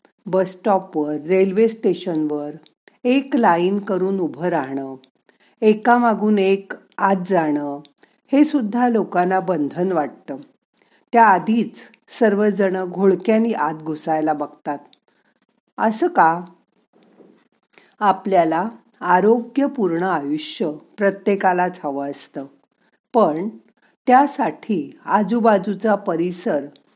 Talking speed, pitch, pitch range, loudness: 80 wpm, 190 Hz, 165-225 Hz, -19 LUFS